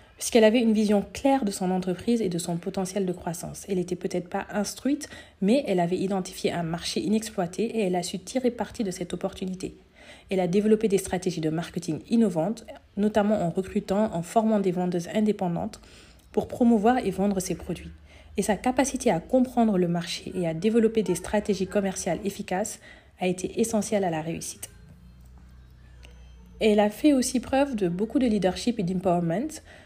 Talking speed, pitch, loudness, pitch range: 175 wpm, 195 Hz, -26 LUFS, 175-220 Hz